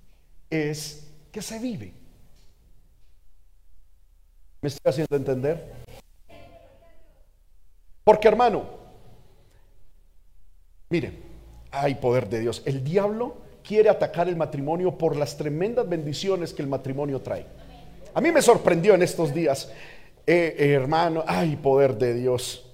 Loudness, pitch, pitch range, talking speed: -24 LUFS, 145 Hz, 115-170 Hz, 115 wpm